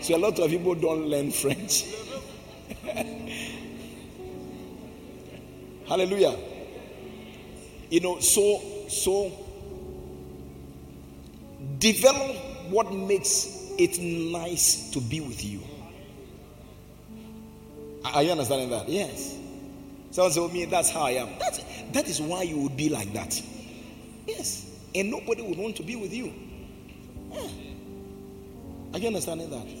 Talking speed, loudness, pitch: 115 wpm, -27 LUFS, 165 Hz